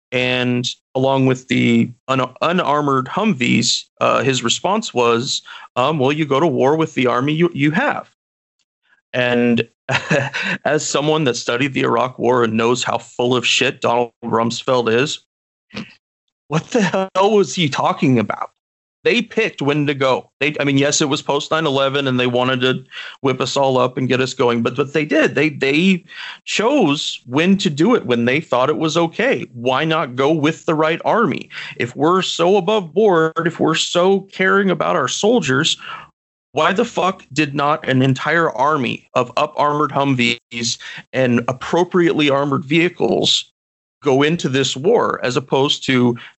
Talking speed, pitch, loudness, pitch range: 170 wpm, 140 Hz, -17 LUFS, 125-165 Hz